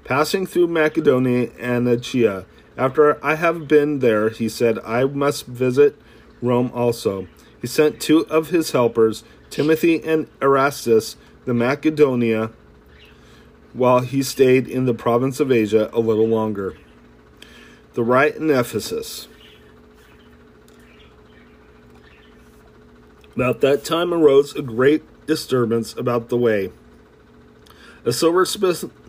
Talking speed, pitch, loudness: 115 wpm, 120 Hz, -19 LUFS